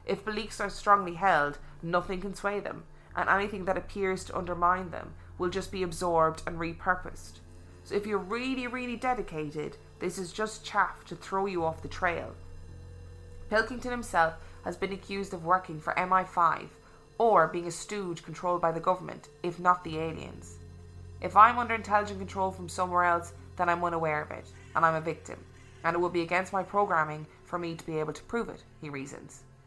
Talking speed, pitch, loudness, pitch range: 190 wpm, 175 Hz, -30 LUFS, 150-195 Hz